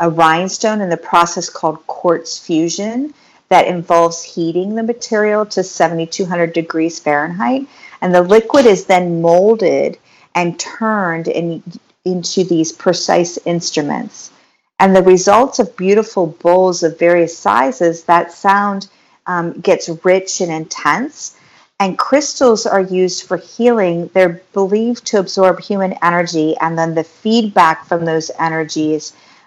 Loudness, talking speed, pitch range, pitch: -14 LUFS, 130 wpm, 165-200 Hz, 180 Hz